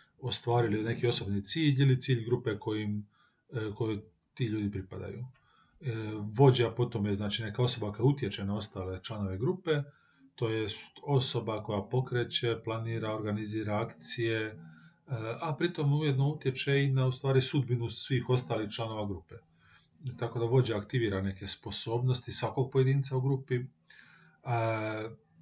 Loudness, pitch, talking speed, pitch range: -32 LUFS, 115 Hz, 125 wpm, 105-130 Hz